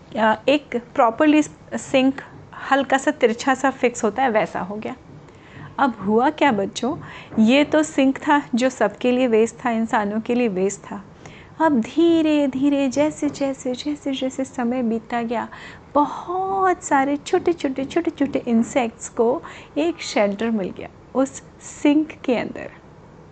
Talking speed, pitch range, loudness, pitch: 150 wpm, 235-295 Hz, -21 LUFS, 265 Hz